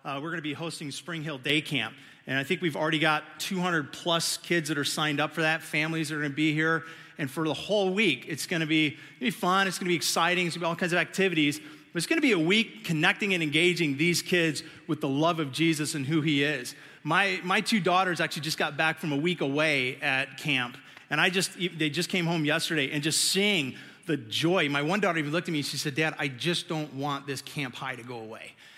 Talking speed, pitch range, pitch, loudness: 260 wpm, 150-175 Hz, 160 Hz, -27 LUFS